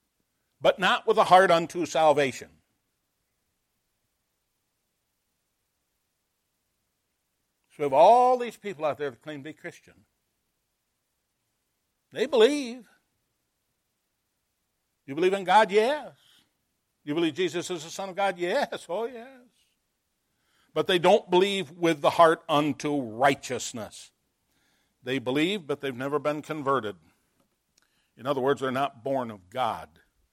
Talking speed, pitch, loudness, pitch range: 125 wpm, 170 Hz, -25 LUFS, 145-215 Hz